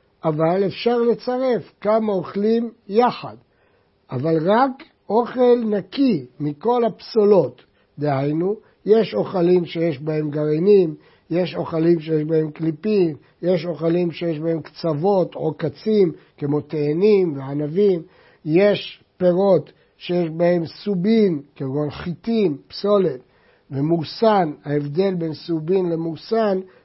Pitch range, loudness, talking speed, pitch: 160-205 Hz, -20 LUFS, 105 wpm, 175 Hz